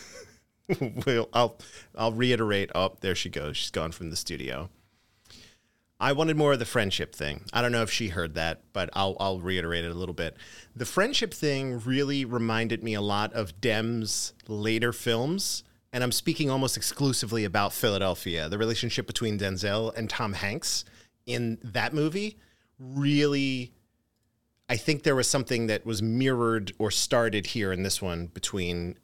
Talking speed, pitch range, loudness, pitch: 165 wpm, 95-125 Hz, -28 LUFS, 115 Hz